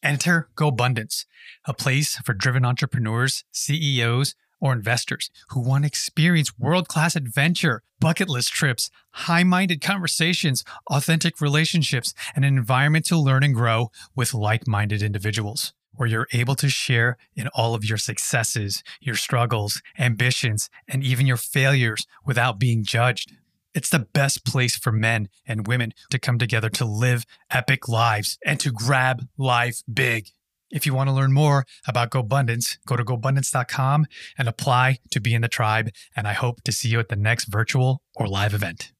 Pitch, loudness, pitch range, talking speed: 125 Hz, -22 LUFS, 115-140 Hz, 165 wpm